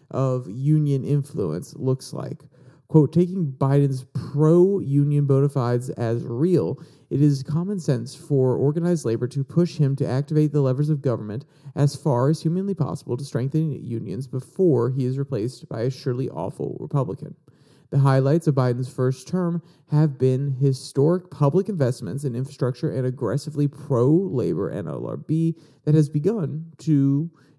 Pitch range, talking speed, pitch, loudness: 130-155 Hz, 150 wpm, 145 Hz, -23 LUFS